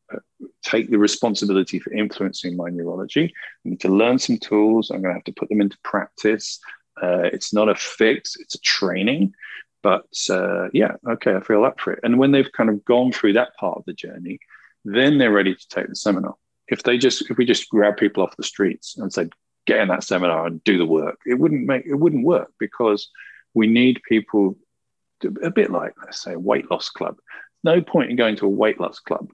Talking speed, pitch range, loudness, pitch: 220 wpm, 100-120 Hz, -20 LUFS, 105 Hz